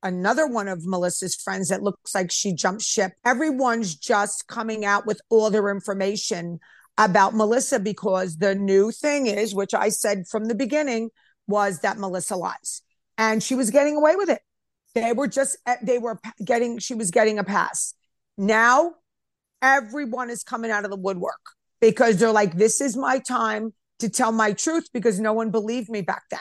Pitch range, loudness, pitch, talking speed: 200-245 Hz, -22 LUFS, 220 Hz, 180 wpm